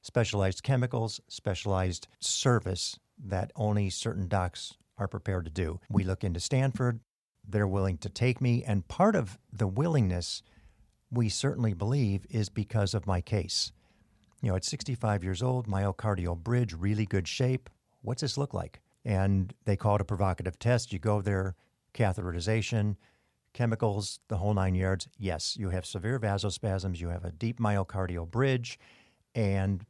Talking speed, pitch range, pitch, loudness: 155 wpm, 95-115 Hz, 105 Hz, -31 LUFS